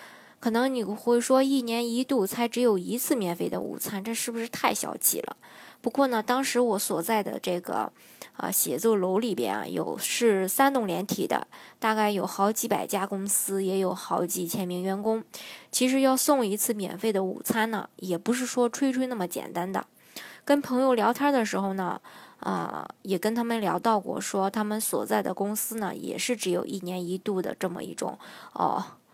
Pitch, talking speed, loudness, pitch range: 220 Hz, 275 characters per minute, -27 LUFS, 190-240 Hz